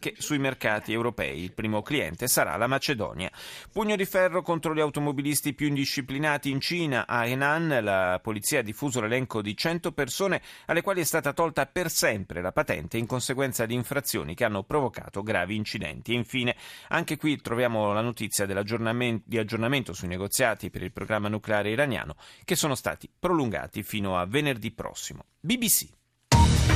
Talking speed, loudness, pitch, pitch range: 160 wpm, -27 LUFS, 125 Hz, 105-150 Hz